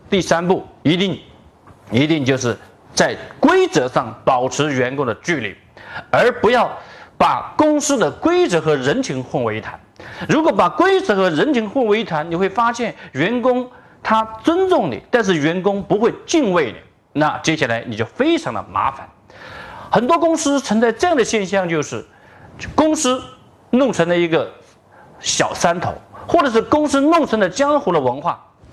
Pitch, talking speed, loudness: 210 Hz, 240 characters per minute, -17 LUFS